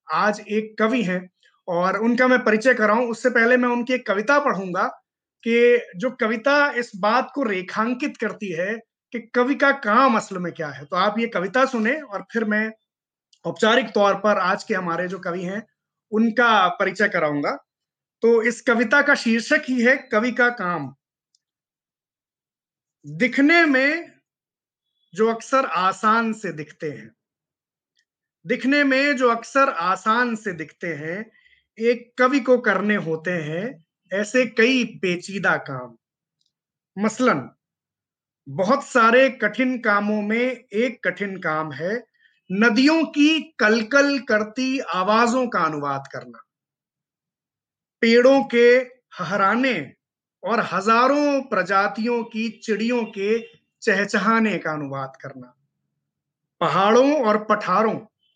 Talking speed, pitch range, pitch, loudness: 125 wpm, 185-250 Hz, 220 Hz, -20 LUFS